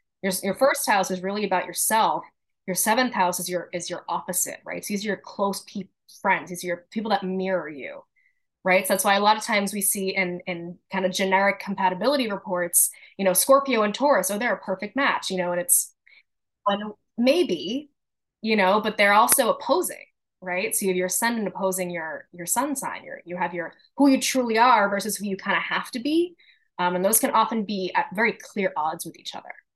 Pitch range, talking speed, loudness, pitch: 185-225 Hz, 230 wpm, -23 LUFS, 200 Hz